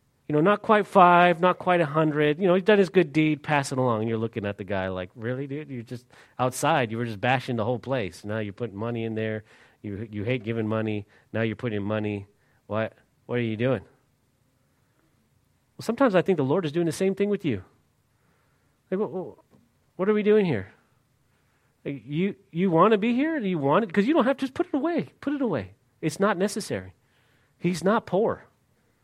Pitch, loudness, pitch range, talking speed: 135 Hz, -25 LUFS, 115-185 Hz, 215 wpm